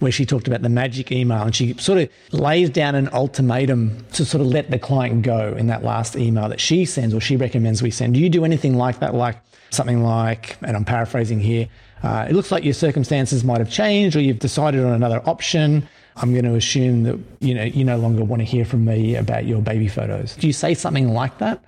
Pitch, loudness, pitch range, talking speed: 125 Hz, -19 LUFS, 115-140 Hz, 240 wpm